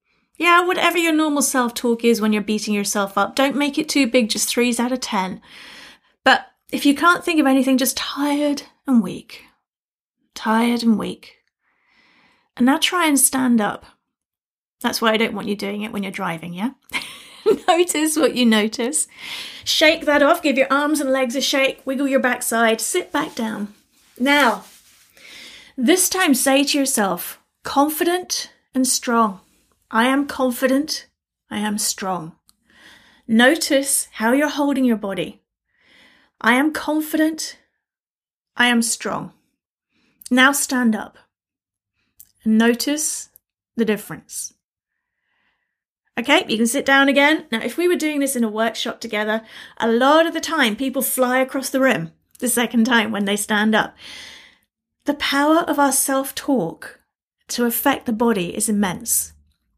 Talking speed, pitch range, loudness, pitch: 155 wpm, 225-285 Hz, -19 LUFS, 255 Hz